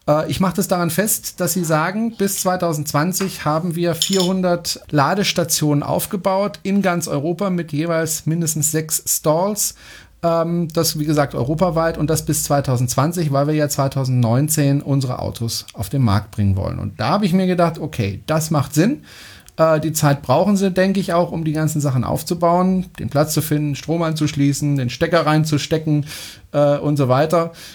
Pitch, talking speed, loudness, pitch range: 155 Hz, 165 wpm, -18 LUFS, 145-175 Hz